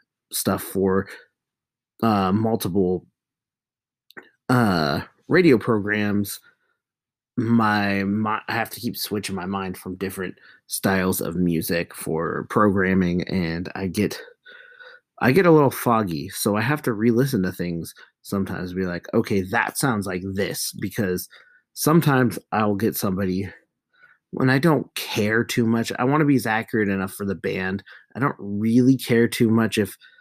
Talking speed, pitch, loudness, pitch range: 145 wpm, 105 Hz, -22 LUFS, 95-120 Hz